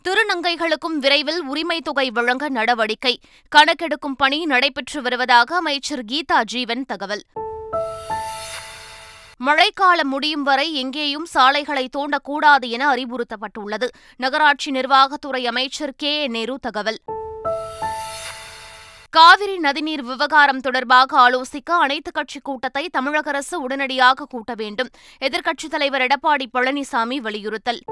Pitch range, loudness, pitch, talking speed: 250-300 Hz, -19 LUFS, 275 Hz, 100 wpm